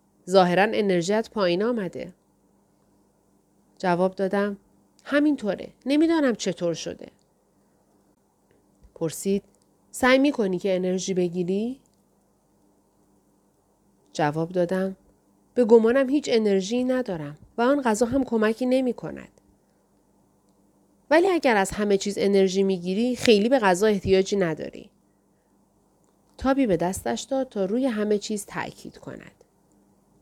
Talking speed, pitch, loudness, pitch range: 105 wpm, 195 Hz, -23 LUFS, 150-235 Hz